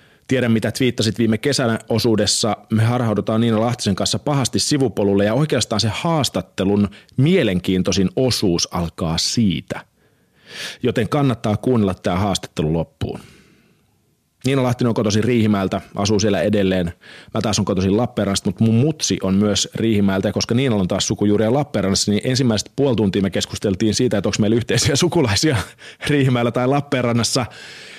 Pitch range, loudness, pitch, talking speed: 100-125 Hz, -18 LUFS, 110 Hz, 145 wpm